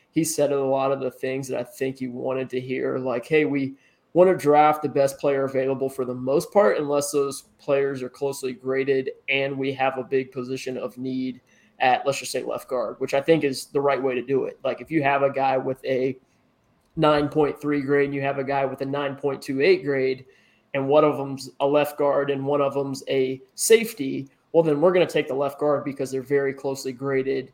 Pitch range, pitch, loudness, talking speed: 130-145 Hz, 135 Hz, -23 LUFS, 225 wpm